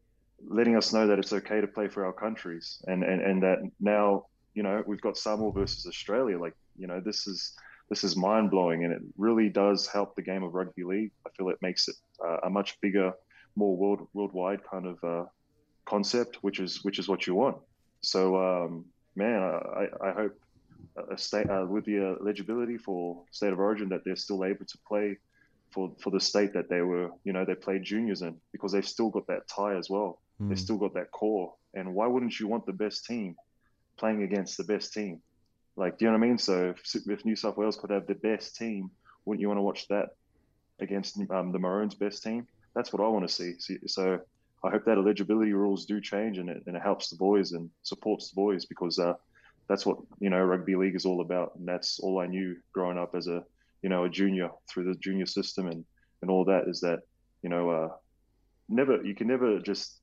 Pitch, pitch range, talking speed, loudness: 100 Hz, 95-105 Hz, 225 wpm, -30 LUFS